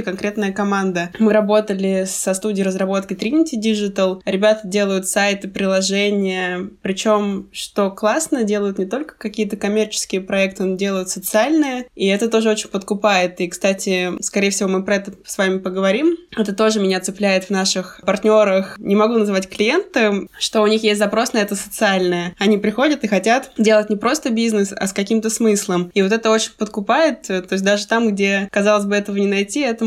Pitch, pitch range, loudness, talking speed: 205 Hz, 195-220 Hz, -18 LUFS, 175 wpm